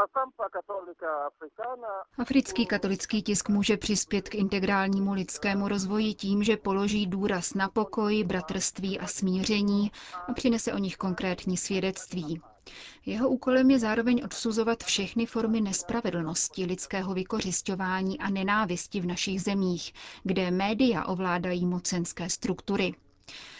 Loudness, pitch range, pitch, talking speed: -29 LUFS, 185-215 Hz, 195 Hz, 110 wpm